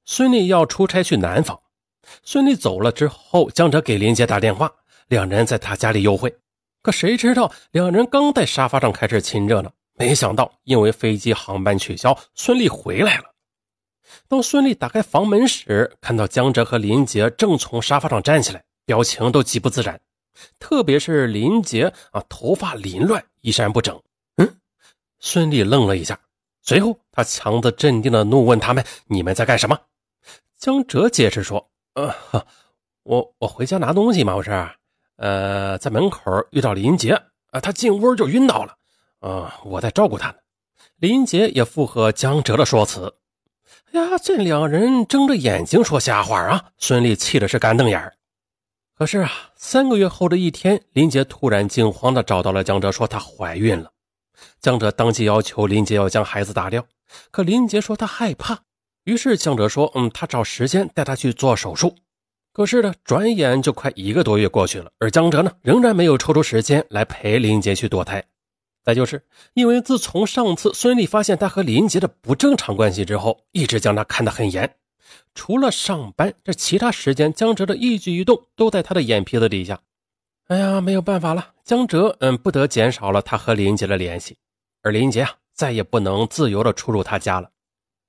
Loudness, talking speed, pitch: -18 LUFS, 270 characters per minute, 130 Hz